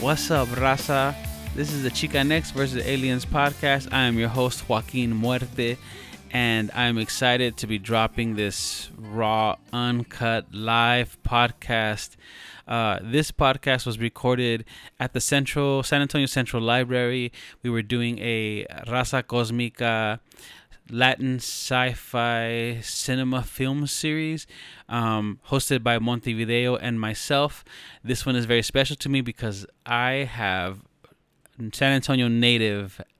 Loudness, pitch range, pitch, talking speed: -24 LUFS, 115-135 Hz, 120 Hz, 130 wpm